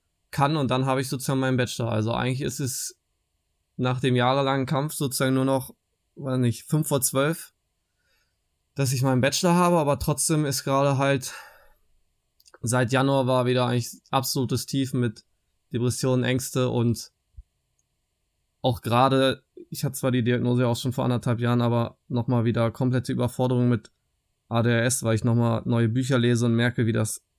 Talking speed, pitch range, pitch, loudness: 160 wpm, 120-135 Hz, 125 Hz, -24 LUFS